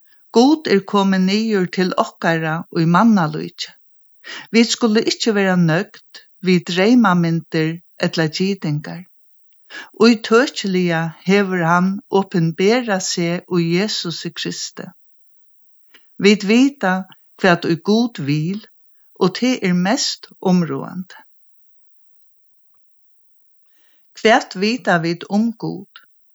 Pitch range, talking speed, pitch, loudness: 170-215 Hz, 105 wpm, 185 Hz, -17 LUFS